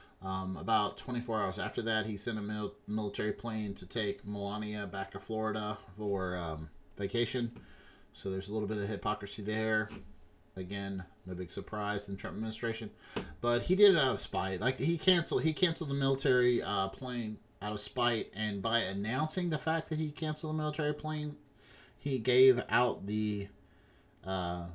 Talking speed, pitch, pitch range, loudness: 175 wpm, 105 Hz, 100-130 Hz, -34 LUFS